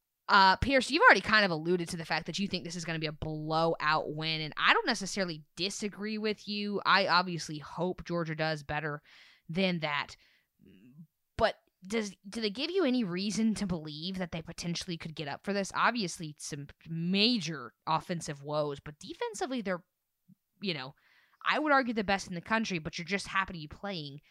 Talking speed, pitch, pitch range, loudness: 195 wpm, 175 Hz, 160-200 Hz, -31 LUFS